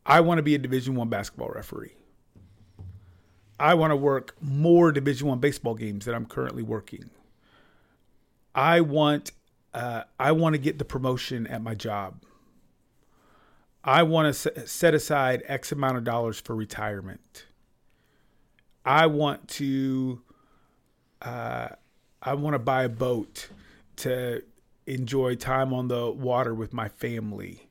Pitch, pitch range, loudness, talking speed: 130 Hz, 115-145 Hz, -26 LUFS, 140 wpm